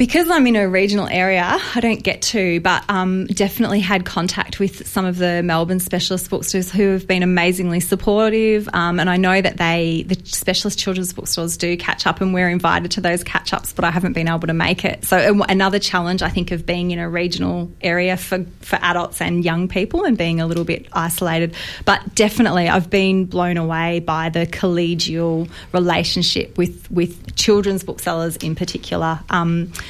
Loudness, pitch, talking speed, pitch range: -18 LUFS, 180 Hz, 195 wpm, 170-195 Hz